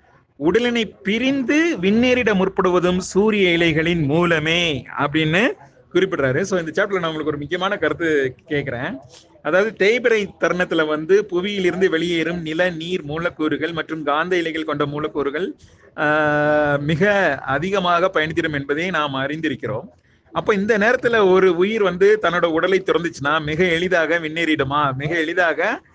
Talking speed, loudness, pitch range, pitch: 95 wpm, -19 LUFS, 155-195 Hz, 170 Hz